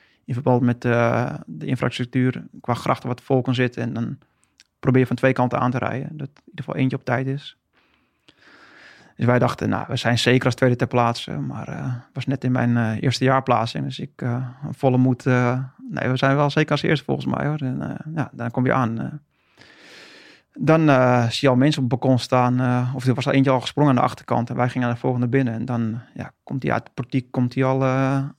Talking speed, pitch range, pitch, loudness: 240 wpm, 125-135 Hz, 130 Hz, -21 LUFS